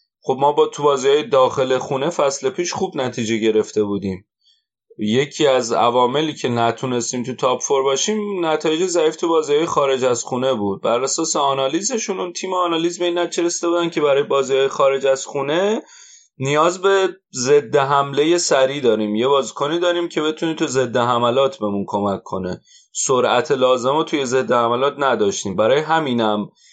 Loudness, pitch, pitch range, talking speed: -18 LUFS, 140 Hz, 130-175 Hz, 160 wpm